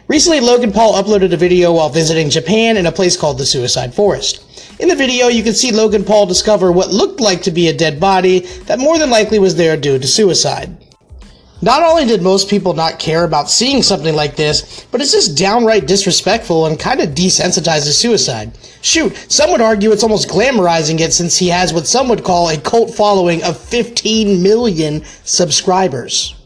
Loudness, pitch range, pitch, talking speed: -12 LUFS, 165-220 Hz, 190 Hz, 195 wpm